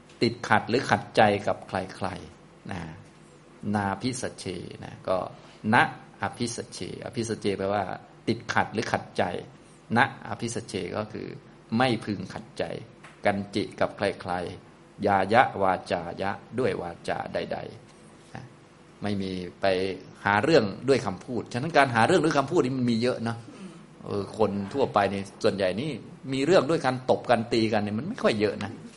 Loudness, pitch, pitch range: -27 LUFS, 110 Hz, 100-125 Hz